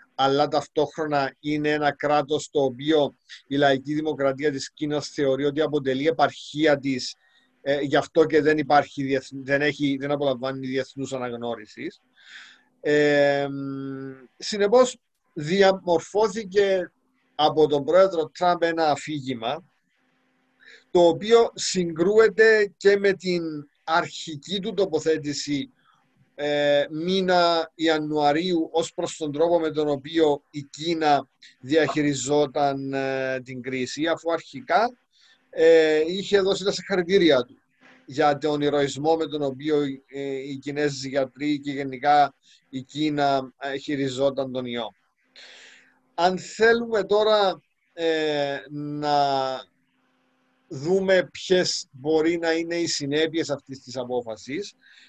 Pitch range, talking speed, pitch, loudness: 140-165 Hz, 115 wpm, 150 Hz, -23 LUFS